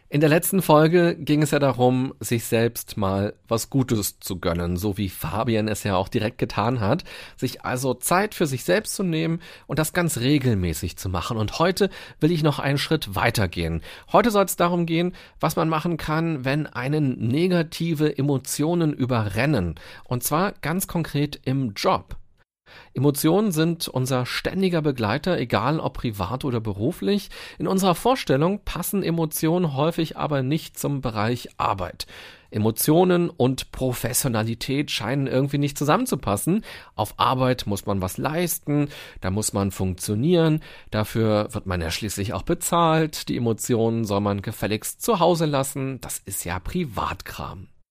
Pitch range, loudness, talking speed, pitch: 110-165 Hz, -23 LUFS, 155 wpm, 135 Hz